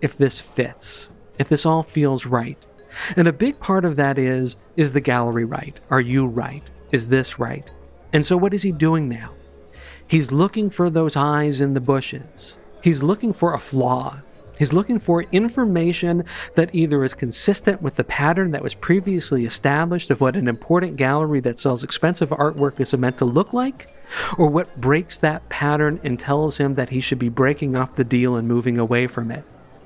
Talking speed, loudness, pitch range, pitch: 190 wpm, -20 LUFS, 130-170 Hz, 145 Hz